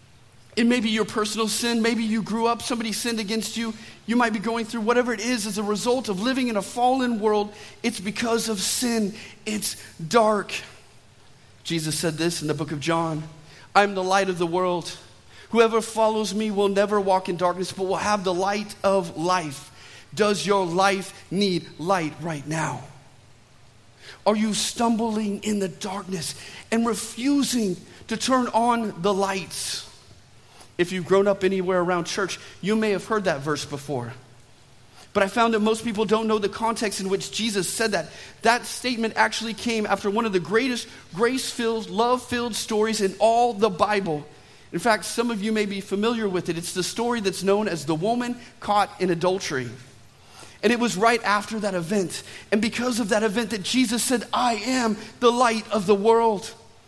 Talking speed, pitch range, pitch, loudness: 185 wpm, 175-225 Hz, 205 Hz, -24 LUFS